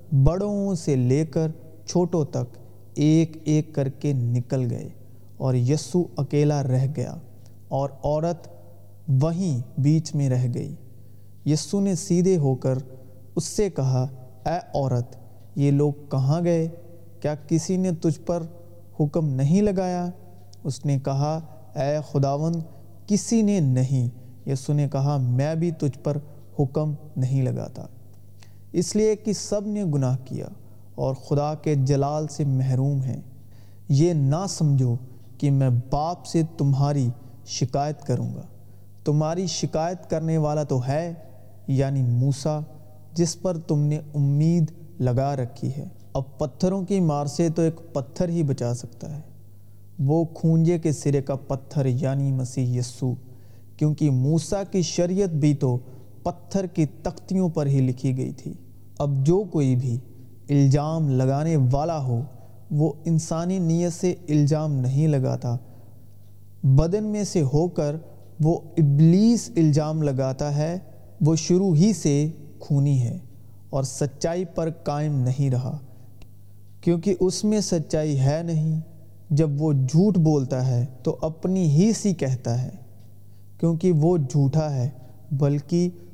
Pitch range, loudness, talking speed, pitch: 125-160 Hz, -24 LUFS, 140 wpm, 145 Hz